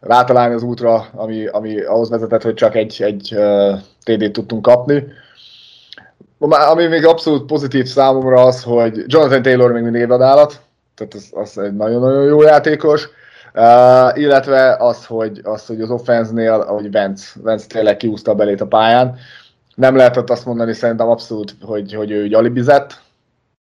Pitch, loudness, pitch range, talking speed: 120 Hz, -13 LUFS, 110-130 Hz, 150 wpm